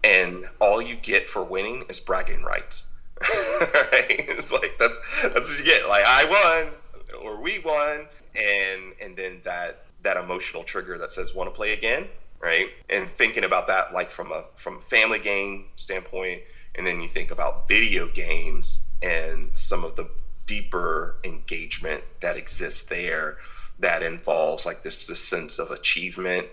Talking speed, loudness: 165 wpm, -23 LUFS